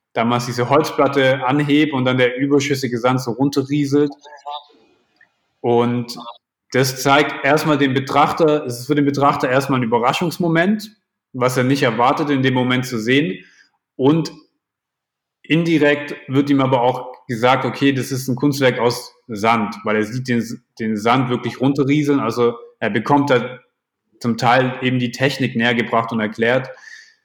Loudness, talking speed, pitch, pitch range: -17 LUFS, 150 wpm, 130 Hz, 120-145 Hz